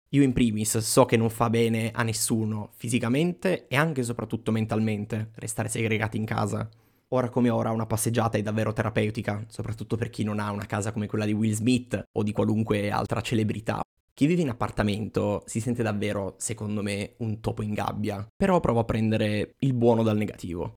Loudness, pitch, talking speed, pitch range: -27 LUFS, 110 Hz, 190 wpm, 105-120 Hz